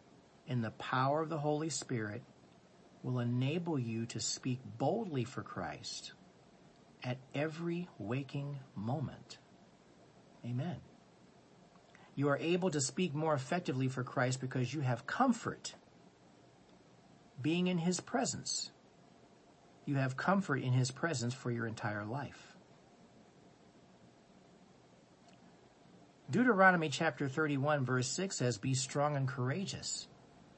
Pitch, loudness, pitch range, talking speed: 135 Hz, -36 LUFS, 125-155 Hz, 110 wpm